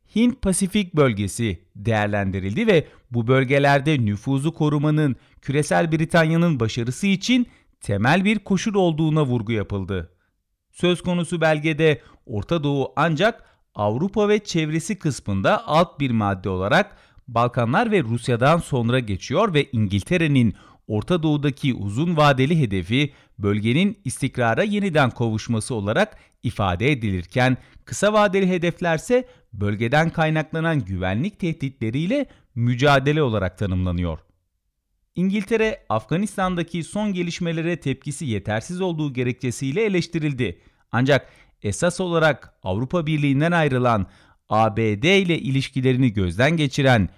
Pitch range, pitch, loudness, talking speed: 110-170 Hz, 140 Hz, -21 LUFS, 105 wpm